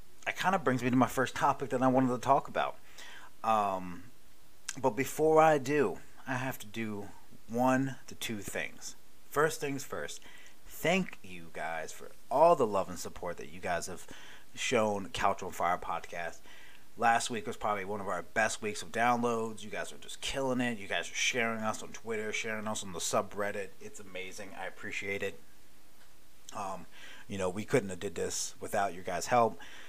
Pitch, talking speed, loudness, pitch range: 120 Hz, 190 wpm, -33 LUFS, 105-135 Hz